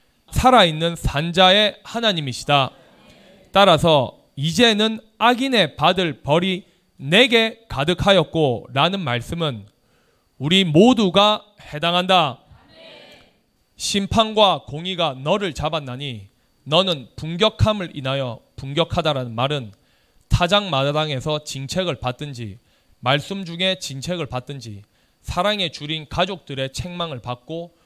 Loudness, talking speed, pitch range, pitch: -19 LUFS, 240 characters per minute, 135-185 Hz, 160 Hz